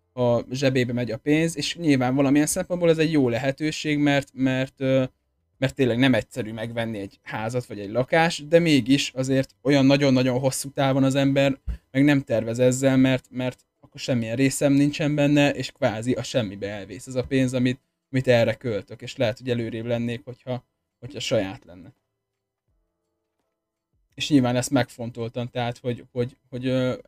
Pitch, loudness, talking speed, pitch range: 130 Hz, -23 LUFS, 165 wpm, 120-140 Hz